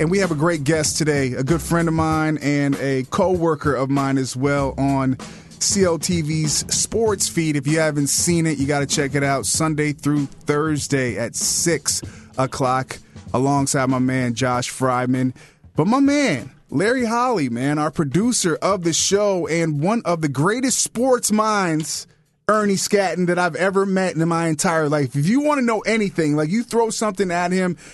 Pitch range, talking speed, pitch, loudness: 140-190 Hz, 185 wpm, 155 Hz, -19 LUFS